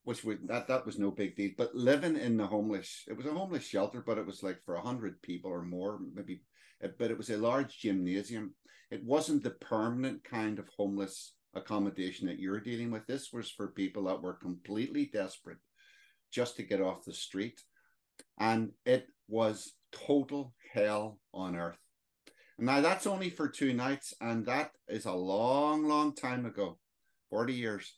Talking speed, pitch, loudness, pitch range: 175 wpm, 110 Hz, -35 LUFS, 100-130 Hz